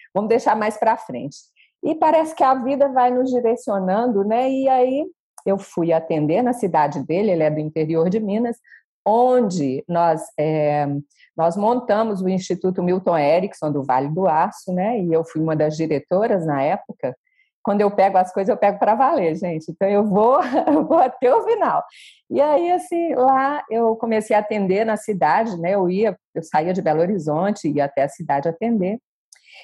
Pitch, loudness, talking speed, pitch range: 200 Hz, -19 LUFS, 185 wpm, 165-245 Hz